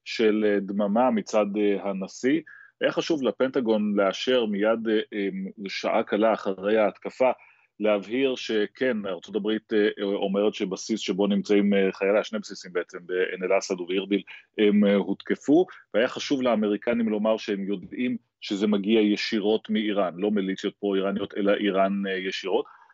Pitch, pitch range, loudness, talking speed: 105 Hz, 100-110 Hz, -25 LUFS, 120 wpm